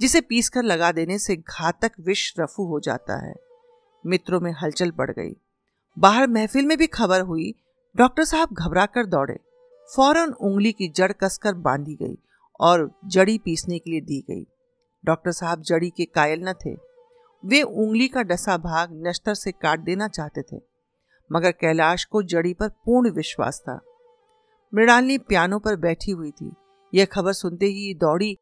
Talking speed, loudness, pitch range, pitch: 165 wpm, -22 LUFS, 170-245 Hz, 195 Hz